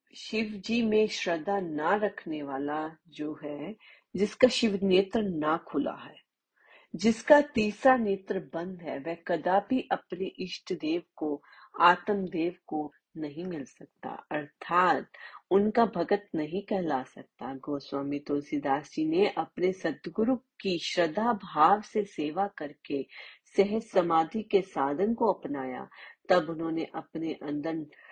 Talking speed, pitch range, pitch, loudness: 130 wpm, 155-210 Hz, 180 Hz, -29 LUFS